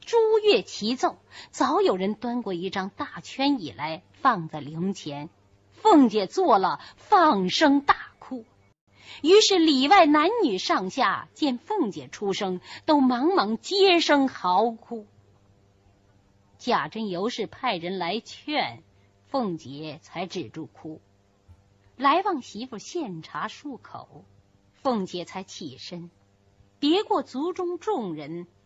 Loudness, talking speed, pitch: -24 LUFS, 165 characters per minute, 215 Hz